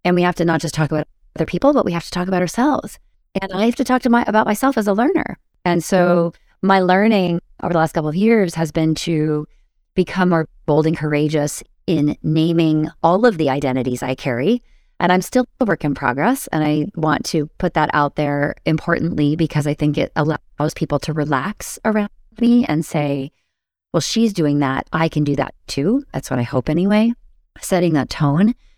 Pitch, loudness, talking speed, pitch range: 165 Hz, -18 LUFS, 210 wpm, 150-195 Hz